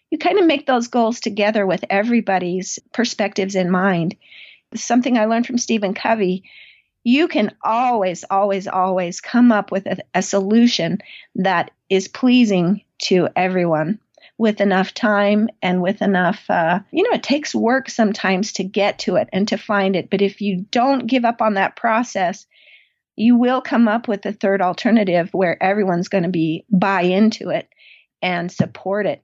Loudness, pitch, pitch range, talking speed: -18 LUFS, 205 Hz, 190-230 Hz, 170 wpm